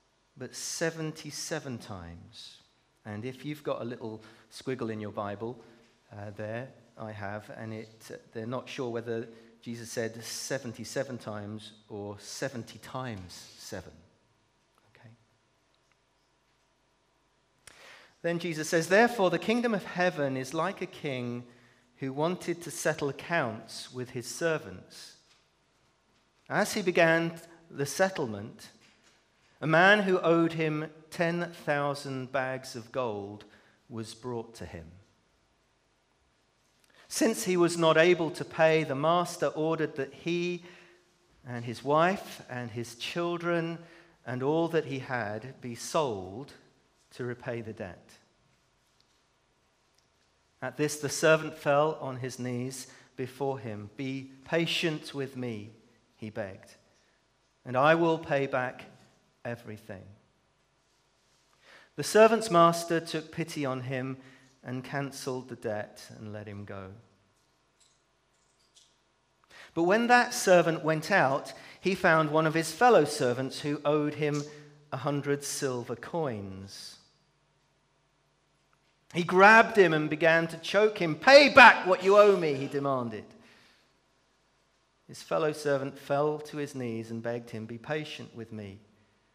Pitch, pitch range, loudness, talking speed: 135 Hz, 115-160 Hz, -28 LUFS, 125 wpm